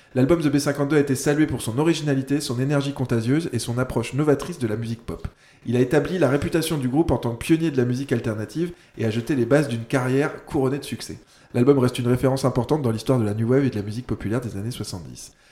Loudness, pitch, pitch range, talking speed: -23 LUFS, 130 Hz, 115-145 Hz, 245 wpm